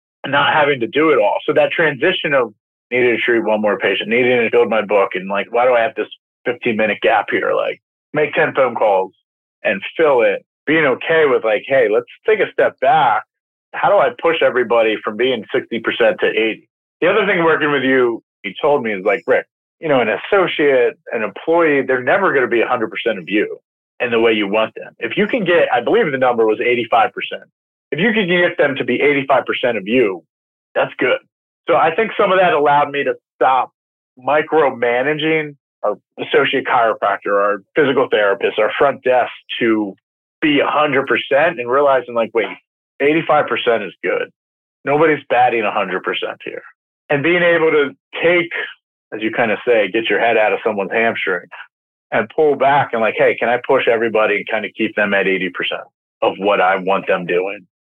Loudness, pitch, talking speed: -16 LUFS, 160 Hz, 195 wpm